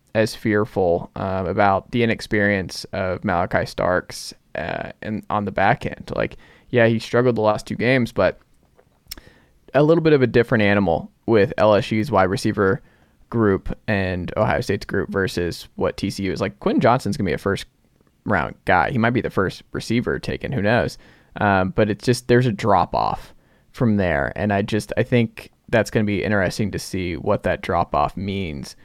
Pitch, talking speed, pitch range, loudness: 105 Hz, 185 wpm, 95-115 Hz, -21 LUFS